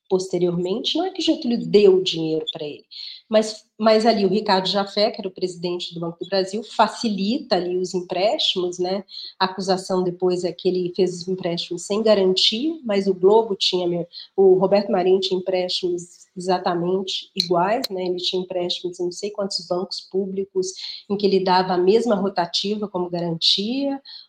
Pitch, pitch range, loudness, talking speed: 190 Hz, 180-210 Hz, -21 LUFS, 175 wpm